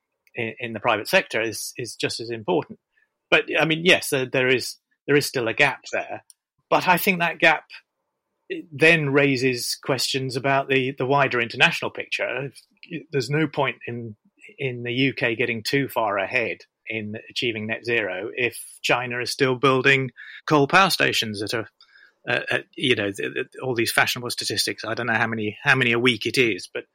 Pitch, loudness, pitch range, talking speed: 135 Hz, -22 LUFS, 120-145 Hz, 180 wpm